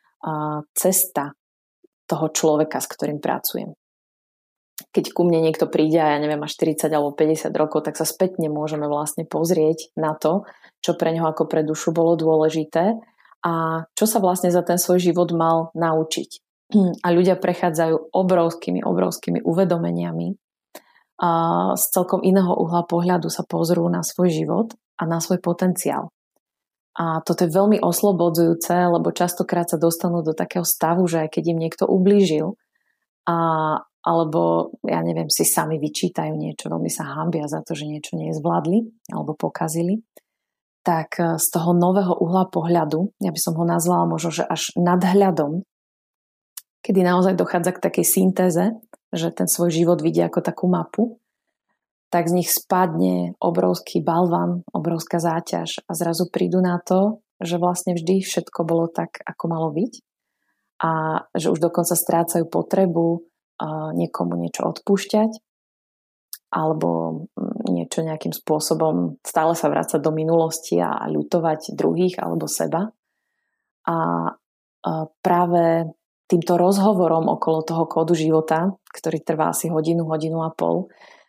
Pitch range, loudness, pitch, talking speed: 160-180 Hz, -21 LUFS, 170 Hz, 140 wpm